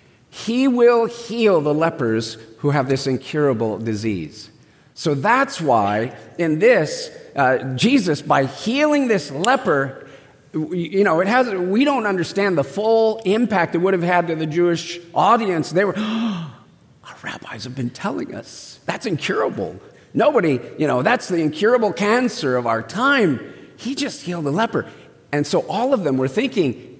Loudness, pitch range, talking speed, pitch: -19 LUFS, 140-230 Hz, 160 wpm, 175 Hz